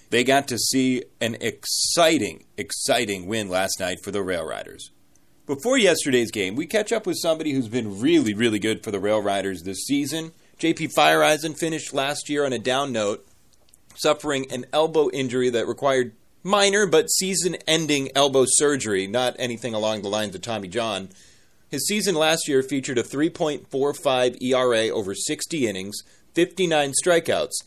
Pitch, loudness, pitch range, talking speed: 140 Hz, -22 LUFS, 120-160 Hz, 155 wpm